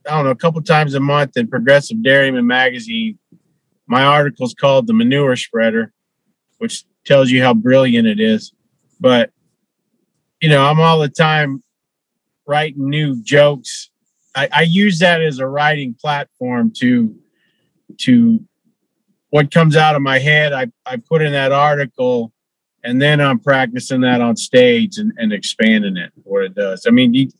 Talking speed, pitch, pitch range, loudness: 160 wpm, 150 Hz, 135-215 Hz, -14 LUFS